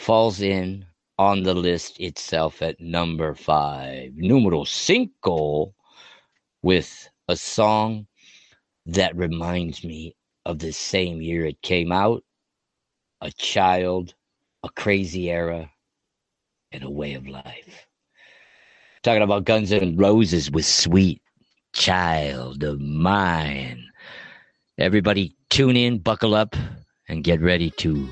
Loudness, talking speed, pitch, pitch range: -22 LUFS, 115 wpm, 85 Hz, 80-100 Hz